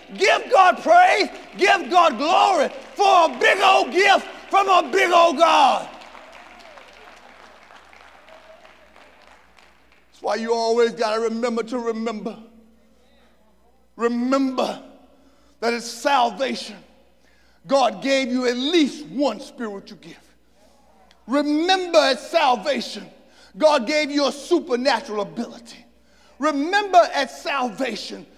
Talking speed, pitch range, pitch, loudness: 105 wpm, 235-320 Hz, 270 Hz, -19 LUFS